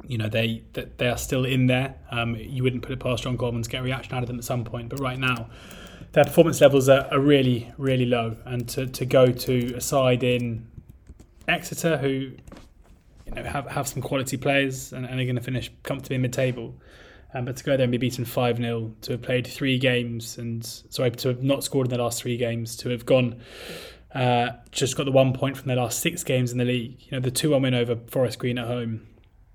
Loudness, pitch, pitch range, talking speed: -24 LUFS, 125 Hz, 120-130 Hz, 235 wpm